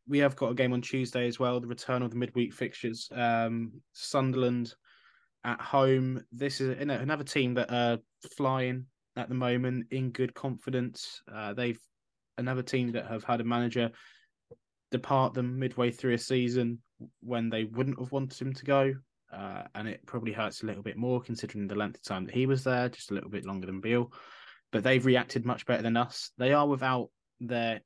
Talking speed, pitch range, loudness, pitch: 195 wpm, 115-130 Hz, -31 LUFS, 125 Hz